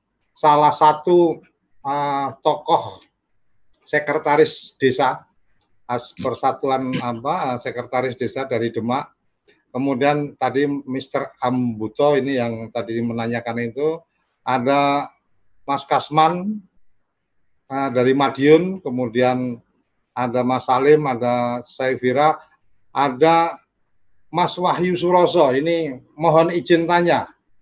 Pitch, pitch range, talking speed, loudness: 135 Hz, 125-155 Hz, 90 wpm, -19 LUFS